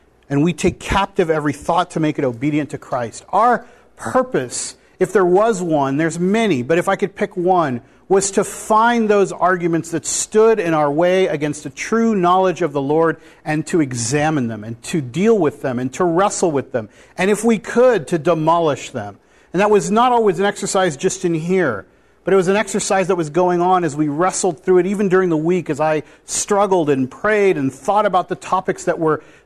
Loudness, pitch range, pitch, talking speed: -17 LUFS, 155-195 Hz, 180 Hz, 210 wpm